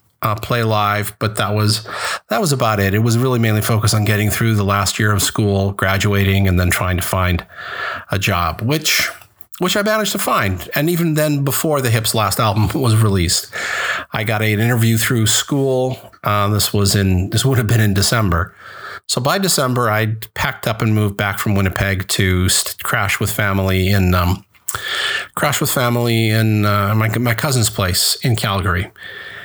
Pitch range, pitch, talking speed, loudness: 100-120 Hz, 105 Hz, 185 wpm, -16 LUFS